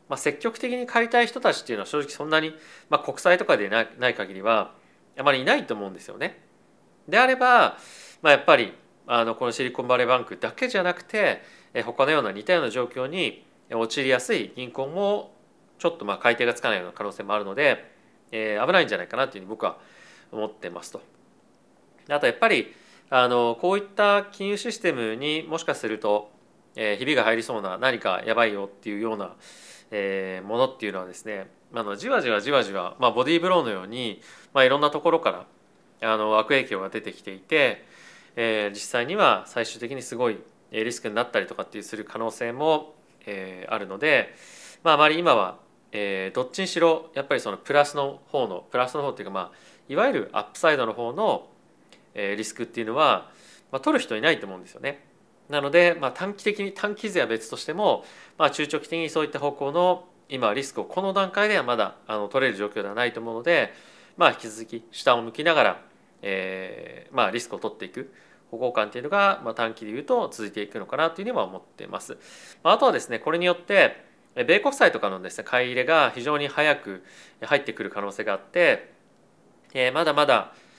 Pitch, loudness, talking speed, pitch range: 135 Hz, -24 LUFS, 405 characters per minute, 110-175 Hz